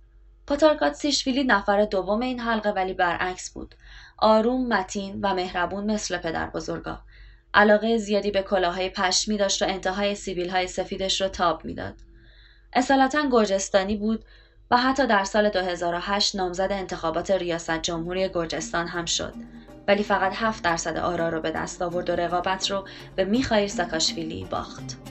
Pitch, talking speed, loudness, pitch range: 190 Hz, 145 wpm, -24 LUFS, 175-210 Hz